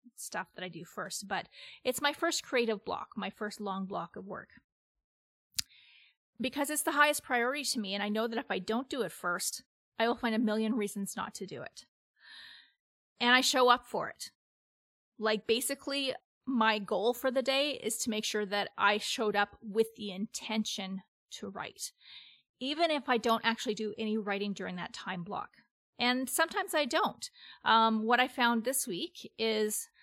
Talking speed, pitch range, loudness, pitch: 185 wpm, 210-260 Hz, -32 LUFS, 225 Hz